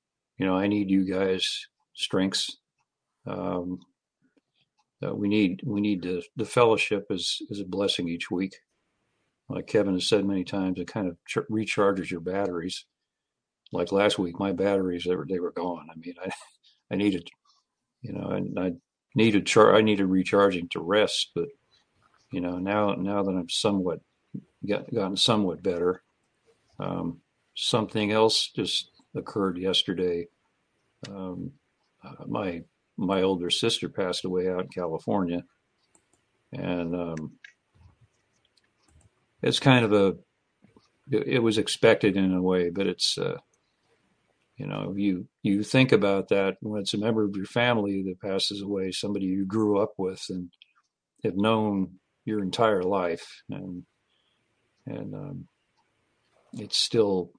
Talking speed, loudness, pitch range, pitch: 145 wpm, -26 LUFS, 90-105 Hz, 95 Hz